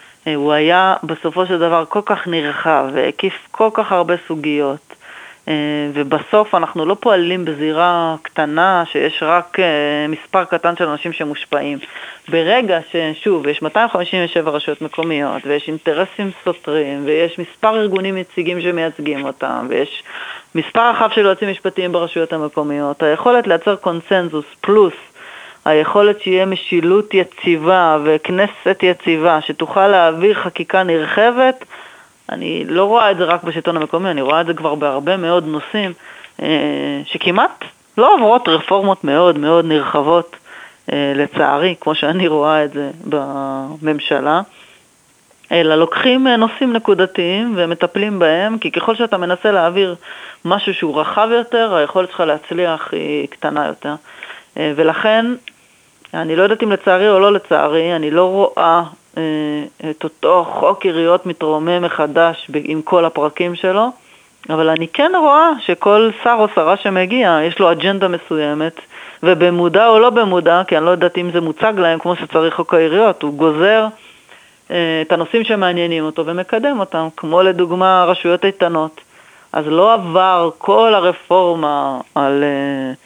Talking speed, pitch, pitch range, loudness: 135 wpm, 175 Hz, 155-195 Hz, -15 LUFS